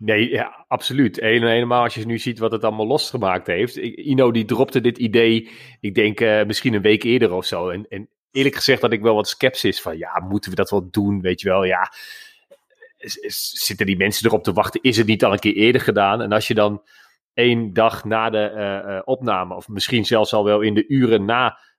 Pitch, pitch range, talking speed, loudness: 110 Hz, 105-120 Hz, 230 wpm, -19 LUFS